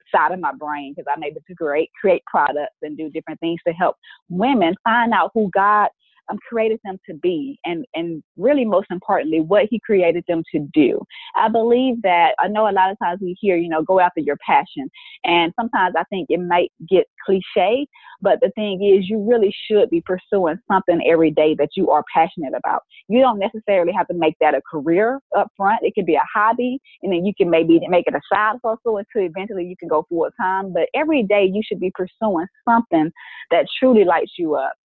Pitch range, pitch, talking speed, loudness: 170-225 Hz, 190 Hz, 215 wpm, -19 LUFS